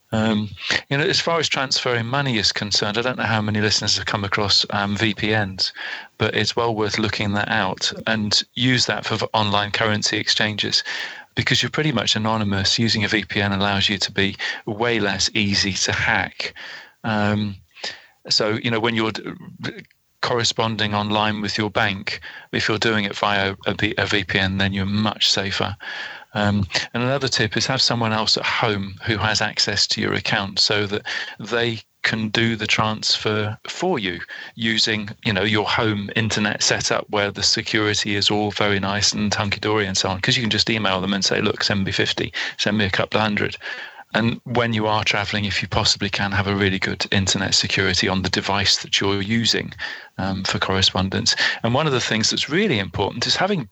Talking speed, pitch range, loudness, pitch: 190 wpm, 100-115 Hz, -20 LUFS, 105 Hz